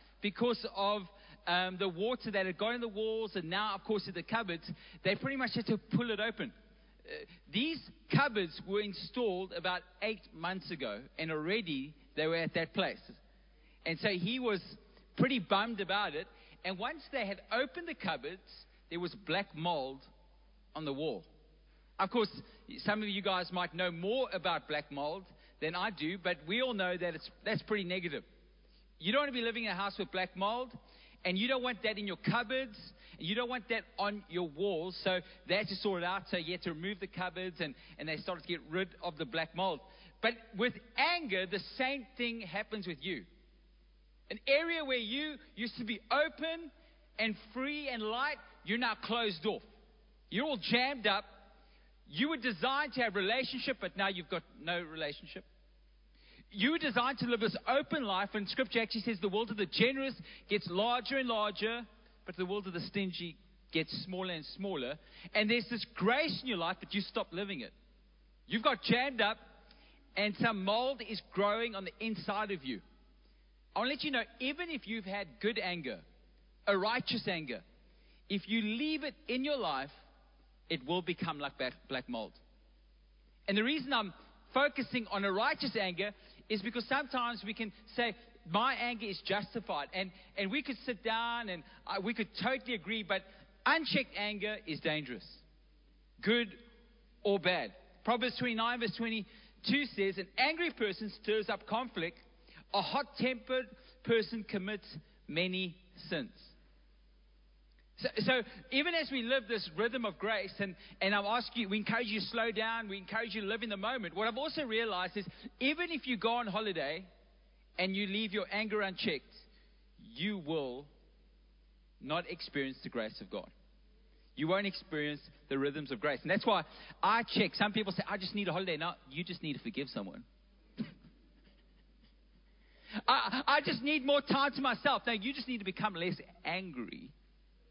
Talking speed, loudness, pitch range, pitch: 185 wpm, -36 LUFS, 185-235 Hz, 210 Hz